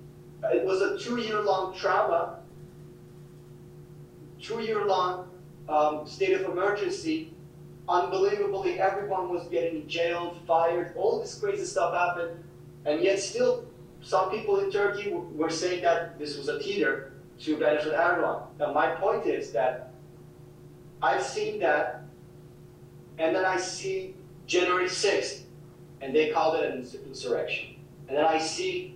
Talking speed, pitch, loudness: 135 wpm, 180 Hz, -28 LUFS